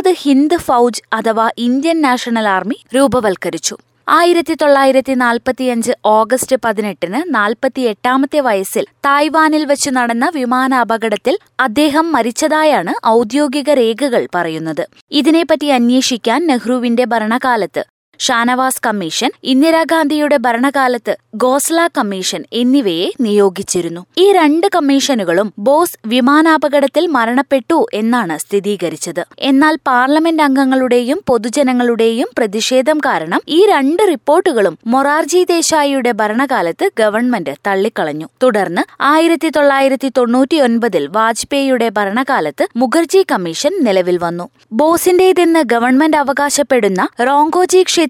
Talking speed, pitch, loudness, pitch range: 90 wpm, 260 Hz, -13 LUFS, 230-300 Hz